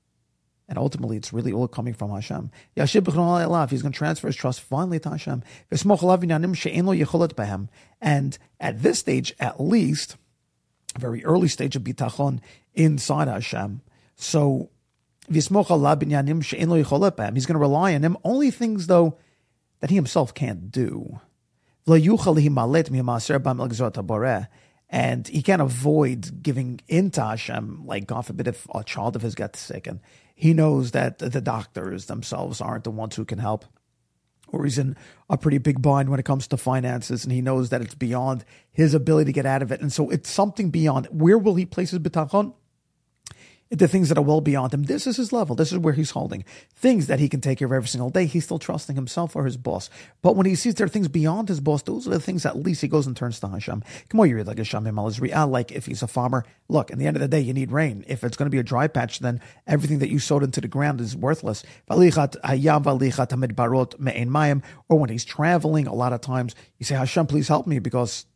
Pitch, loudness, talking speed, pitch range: 140 Hz, -23 LUFS, 195 wpm, 125-160 Hz